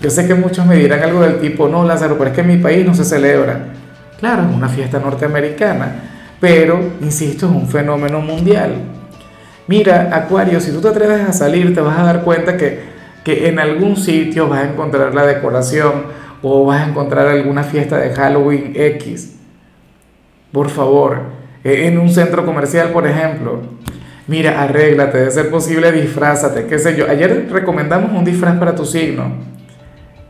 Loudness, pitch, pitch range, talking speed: -13 LUFS, 150 Hz, 140-170 Hz, 170 wpm